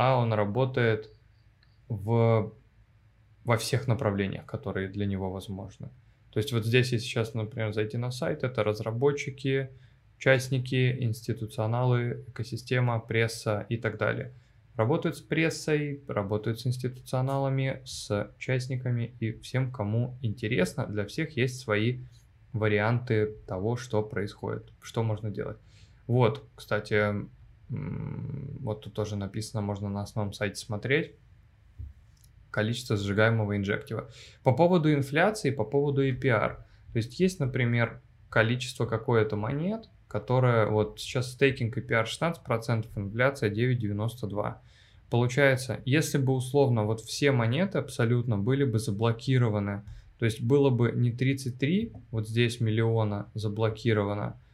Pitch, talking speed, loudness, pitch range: 115 Hz, 120 wpm, -29 LUFS, 110-130 Hz